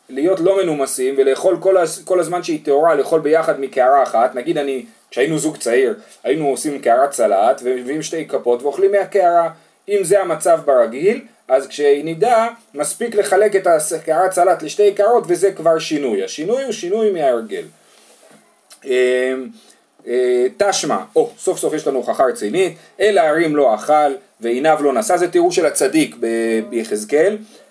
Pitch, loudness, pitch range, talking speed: 175 Hz, -16 LUFS, 145-205 Hz, 145 wpm